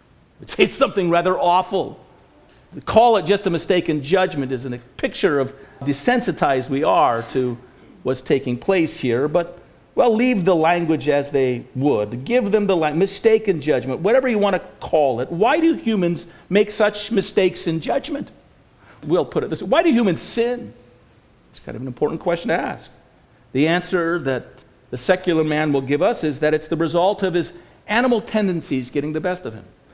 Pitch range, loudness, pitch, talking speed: 145-200 Hz, -20 LUFS, 175 Hz, 190 wpm